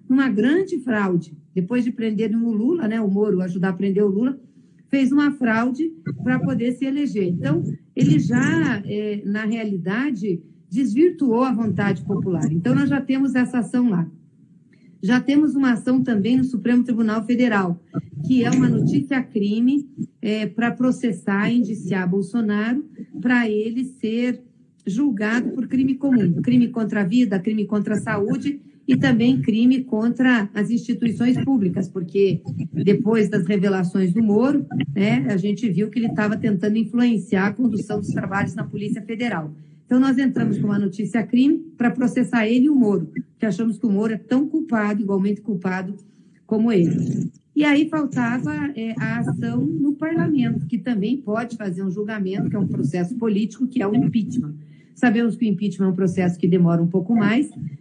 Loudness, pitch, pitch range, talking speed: -21 LUFS, 220 Hz, 200-245 Hz, 170 wpm